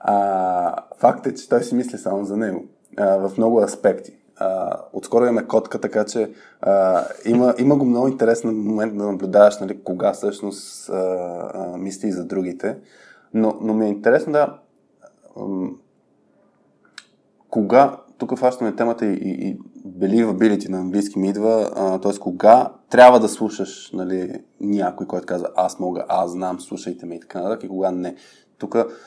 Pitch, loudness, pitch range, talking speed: 105 Hz, -20 LUFS, 95-115 Hz, 165 wpm